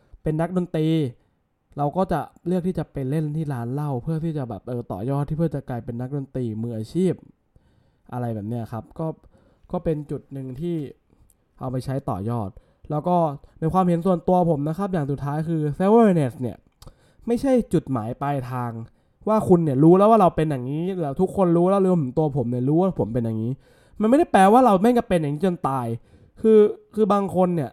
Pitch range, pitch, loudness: 125-180 Hz, 155 Hz, -22 LUFS